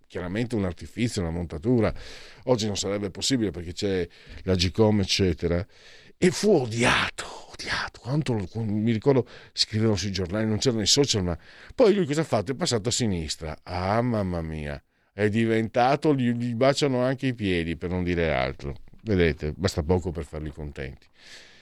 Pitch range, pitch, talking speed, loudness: 85-120 Hz, 105 Hz, 165 wpm, -25 LUFS